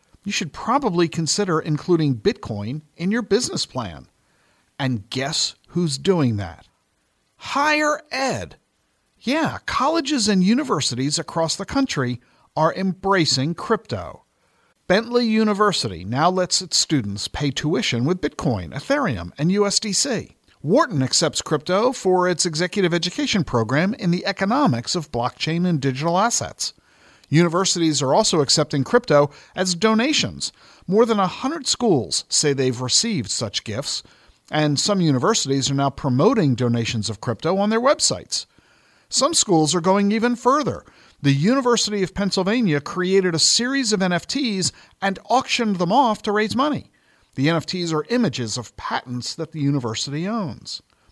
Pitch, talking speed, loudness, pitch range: 175 Hz, 135 wpm, -20 LUFS, 140-210 Hz